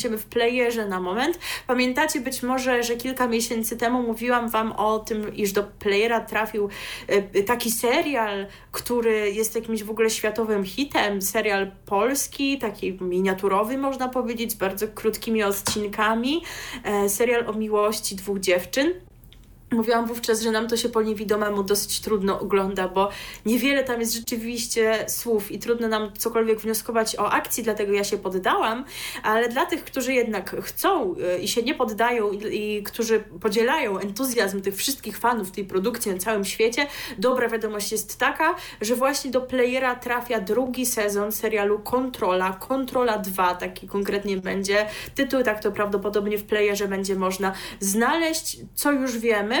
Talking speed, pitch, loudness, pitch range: 150 wpm, 220 Hz, -24 LUFS, 205-245 Hz